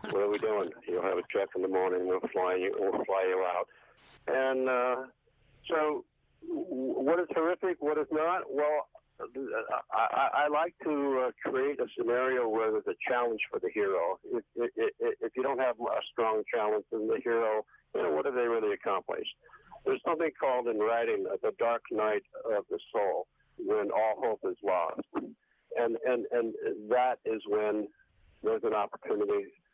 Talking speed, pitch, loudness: 175 wpm, 190 Hz, -31 LUFS